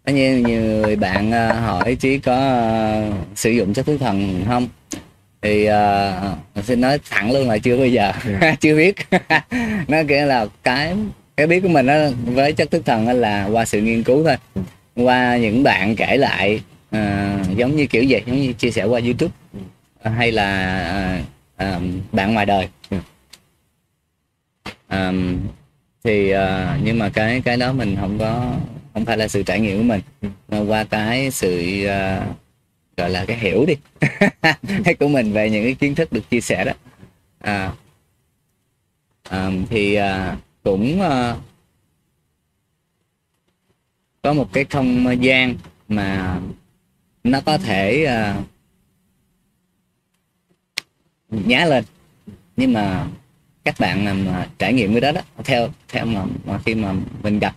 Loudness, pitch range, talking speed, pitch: -18 LUFS, 100-130 Hz, 150 wpm, 115 Hz